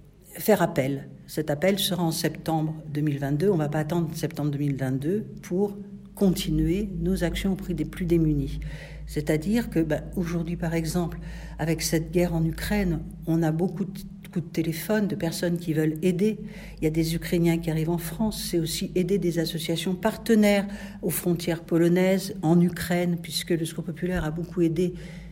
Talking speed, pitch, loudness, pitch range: 175 wpm, 170 Hz, -26 LUFS, 160-185 Hz